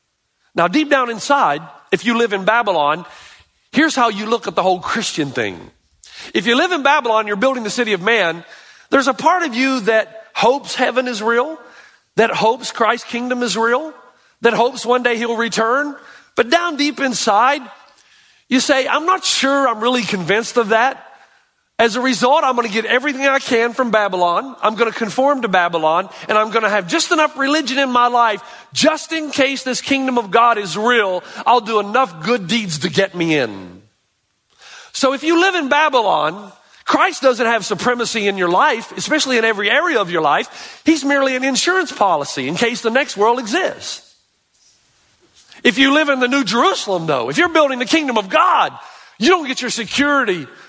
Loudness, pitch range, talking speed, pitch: -16 LUFS, 220-280 Hz, 190 wpm, 245 Hz